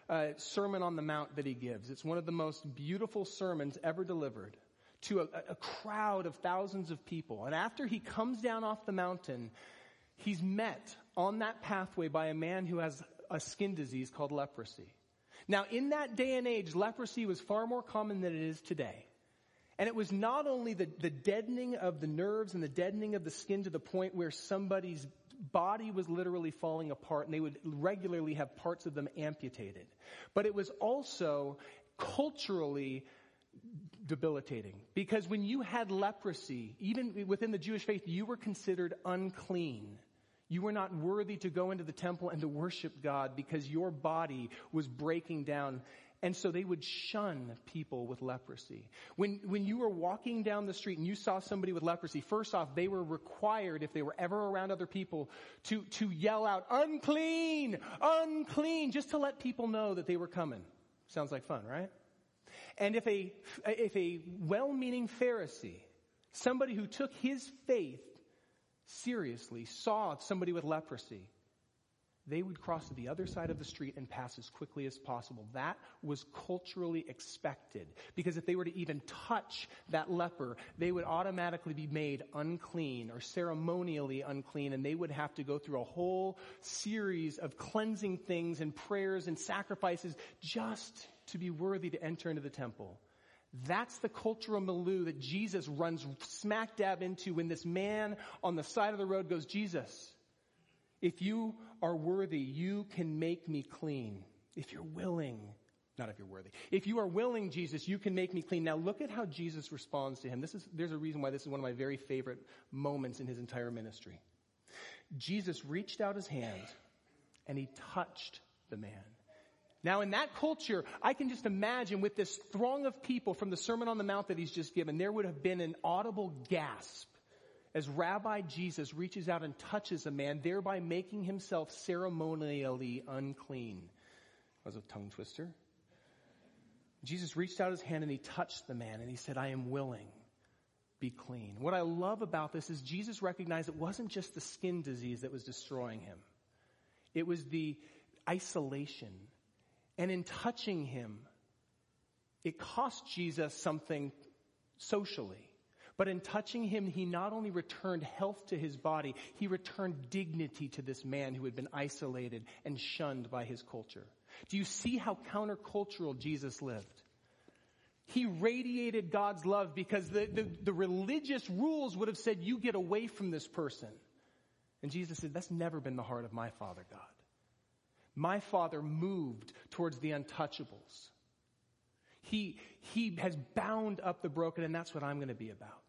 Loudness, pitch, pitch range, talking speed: -39 LUFS, 170 Hz, 140-200 Hz, 175 wpm